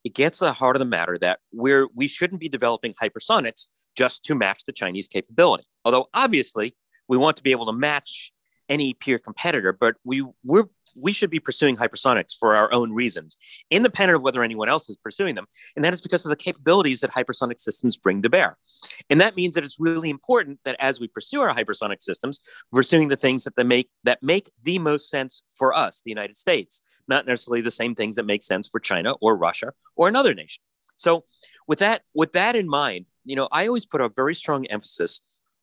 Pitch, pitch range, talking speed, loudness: 135 Hz, 125-165 Hz, 215 wpm, -22 LUFS